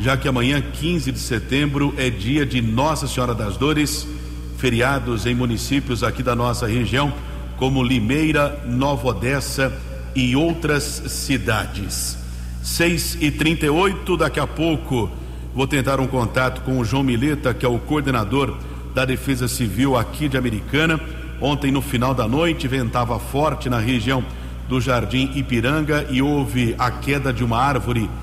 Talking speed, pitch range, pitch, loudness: 150 wpm, 120-140 Hz, 130 Hz, -20 LUFS